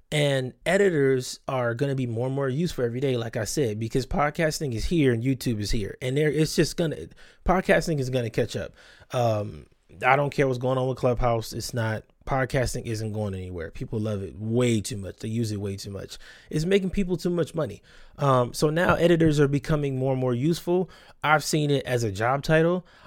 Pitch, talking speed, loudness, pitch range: 130 Hz, 215 wpm, -25 LUFS, 115-155 Hz